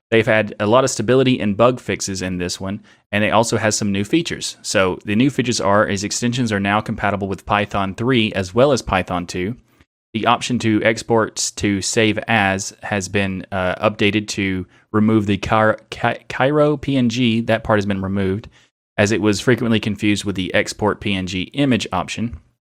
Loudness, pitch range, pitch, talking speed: -18 LUFS, 100-115 Hz, 105 Hz, 185 wpm